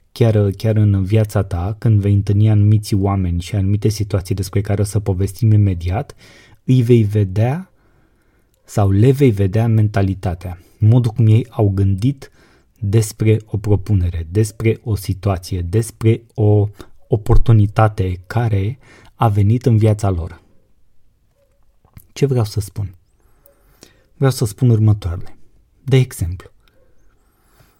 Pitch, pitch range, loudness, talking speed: 105 Hz, 100-115 Hz, -17 LUFS, 125 wpm